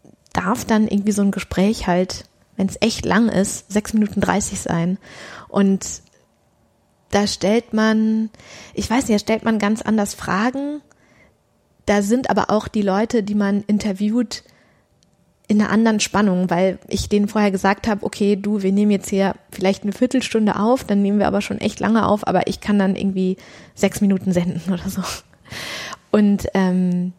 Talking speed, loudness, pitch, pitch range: 170 wpm, -19 LUFS, 205 Hz, 195-215 Hz